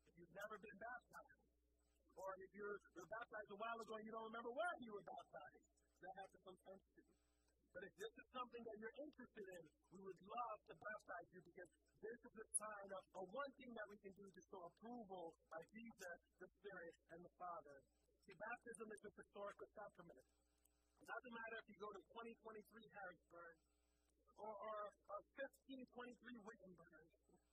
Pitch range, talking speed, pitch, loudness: 180-230 Hz, 185 wpm, 205 Hz, -57 LUFS